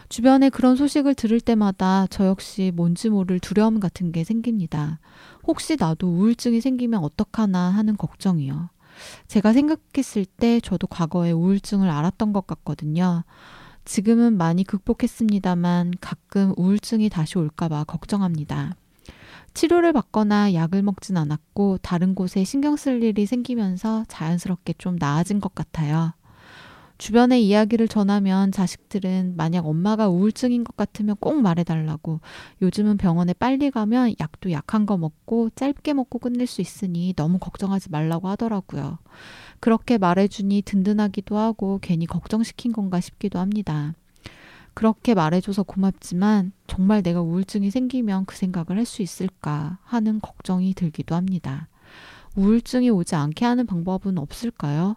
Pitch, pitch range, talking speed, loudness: 195 Hz, 175-220 Hz, 330 characters per minute, -22 LUFS